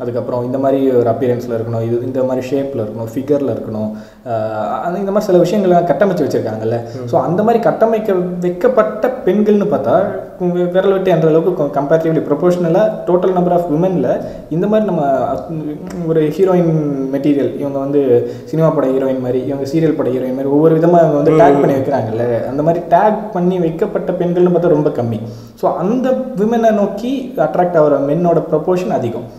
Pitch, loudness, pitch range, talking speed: 160 Hz, -14 LUFS, 130-180 Hz, 160 wpm